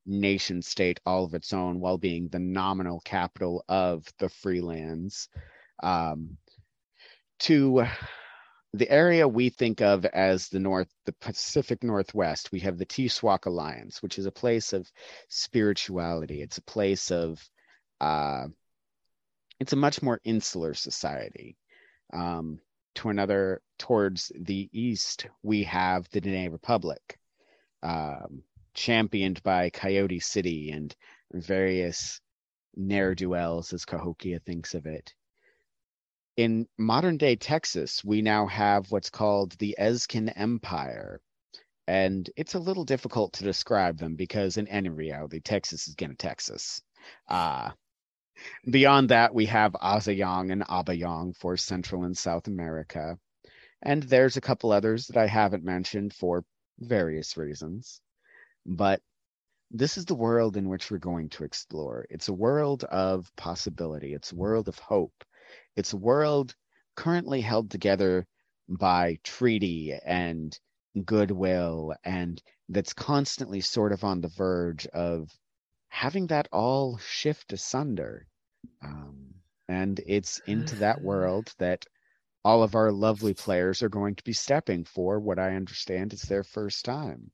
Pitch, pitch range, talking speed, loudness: 95 Hz, 90-110 Hz, 135 wpm, -28 LUFS